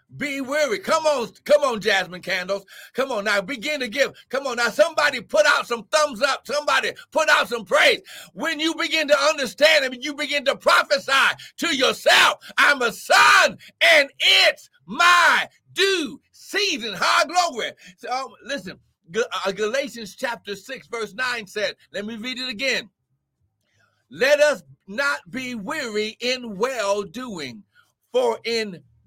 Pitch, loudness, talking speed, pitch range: 265 Hz, -20 LUFS, 155 wpm, 220-300 Hz